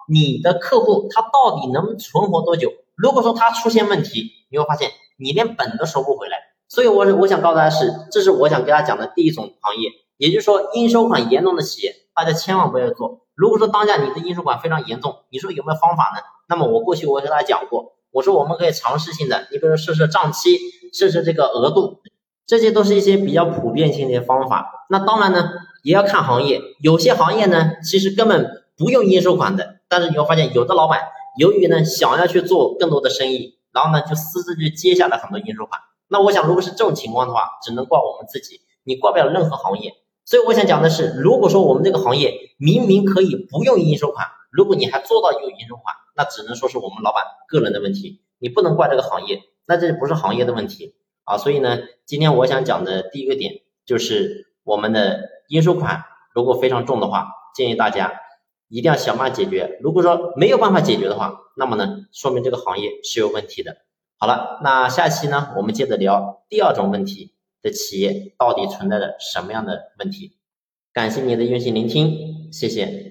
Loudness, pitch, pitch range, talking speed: -17 LUFS, 185 Hz, 155-230 Hz, 335 characters per minute